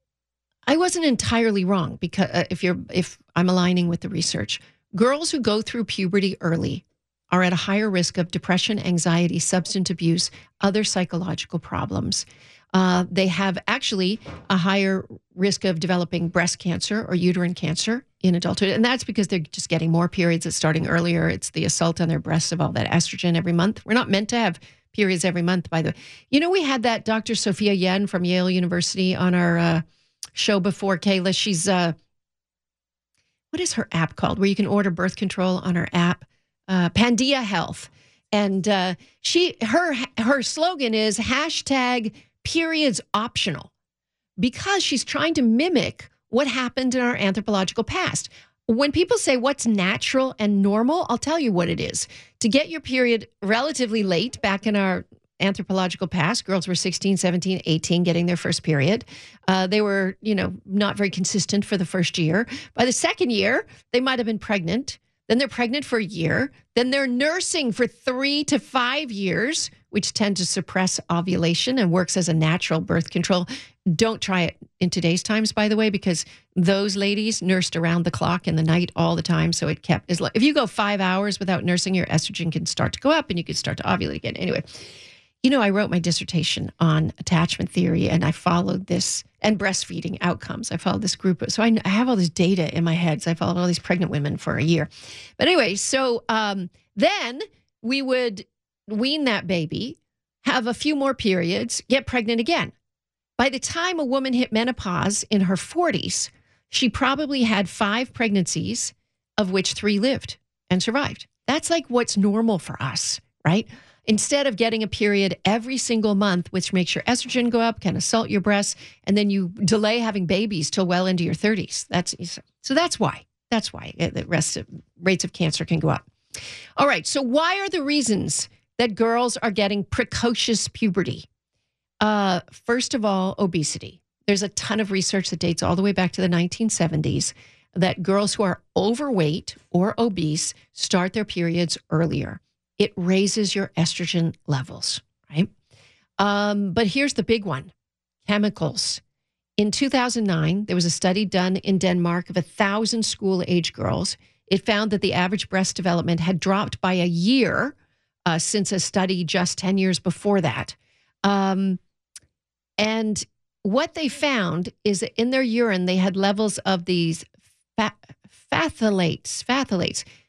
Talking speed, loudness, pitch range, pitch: 180 wpm, -22 LUFS, 175-225 Hz, 195 Hz